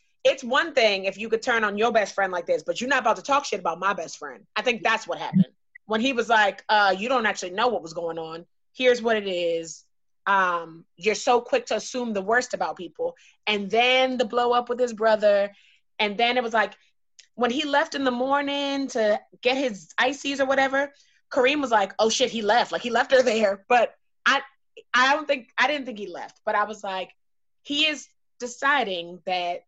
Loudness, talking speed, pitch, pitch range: -24 LUFS, 225 wpm, 230 Hz, 200-260 Hz